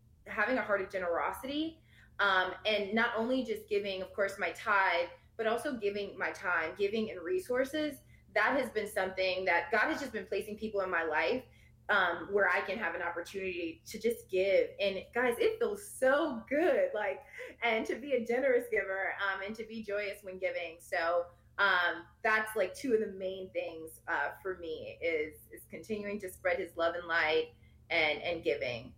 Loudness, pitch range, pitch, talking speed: -33 LUFS, 185-245 Hz, 205 Hz, 190 wpm